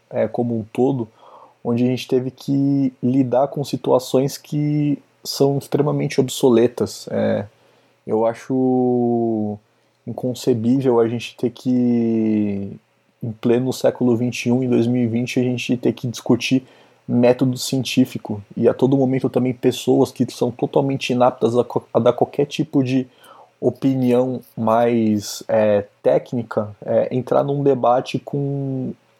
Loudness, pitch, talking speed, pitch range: -19 LUFS, 125 Hz, 125 wpm, 115-135 Hz